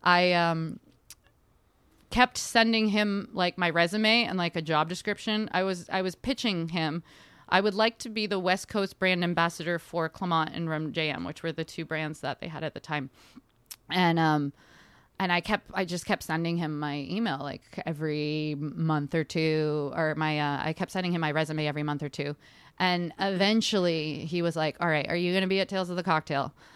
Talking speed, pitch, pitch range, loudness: 205 wpm, 170 Hz, 155-185 Hz, -28 LUFS